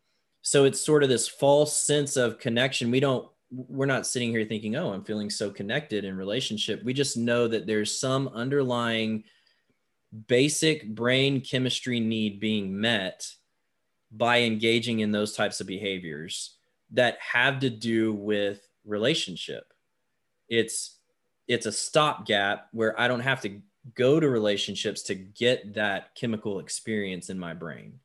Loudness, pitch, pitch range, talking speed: -26 LUFS, 115 Hz, 105-130 Hz, 150 wpm